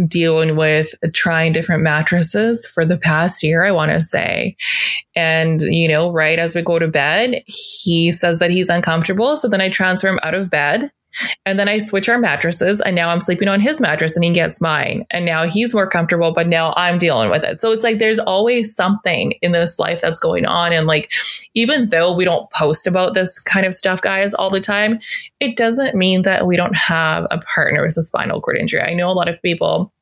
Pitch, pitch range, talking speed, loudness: 175 Hz, 165-205 Hz, 220 wpm, -15 LUFS